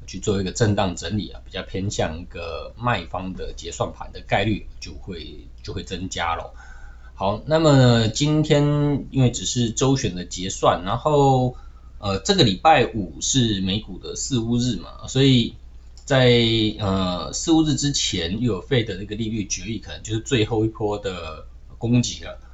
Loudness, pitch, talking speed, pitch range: -21 LUFS, 105 Hz, 245 characters per minute, 90-125 Hz